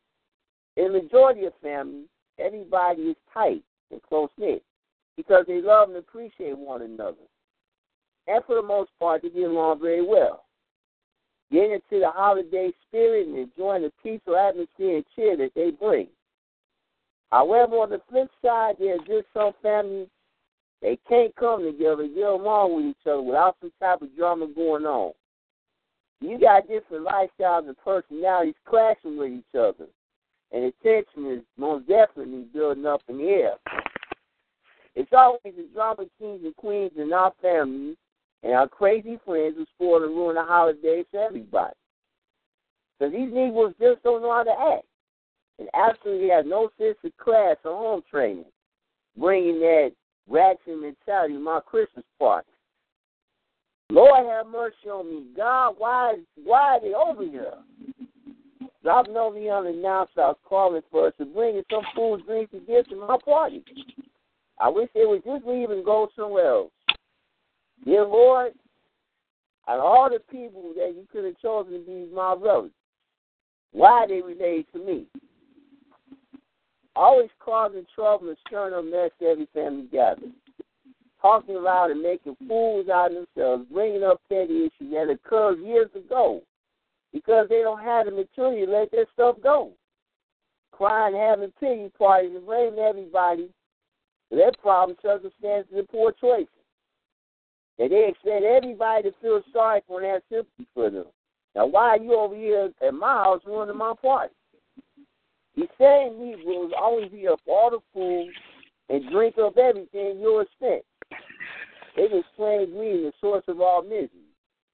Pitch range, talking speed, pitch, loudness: 180-260 Hz, 160 wpm, 210 Hz, -23 LUFS